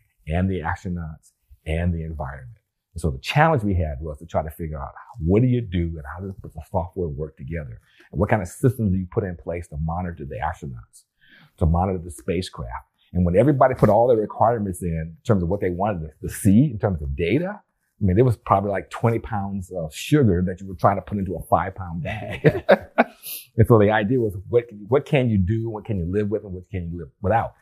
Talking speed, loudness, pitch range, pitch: 240 wpm, -23 LUFS, 85-110 Hz, 95 Hz